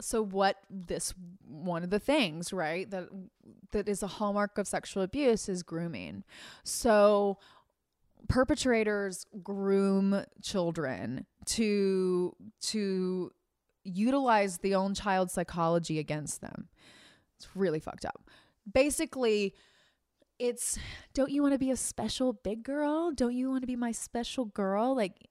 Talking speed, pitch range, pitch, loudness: 130 wpm, 190-240 Hz, 205 Hz, -31 LUFS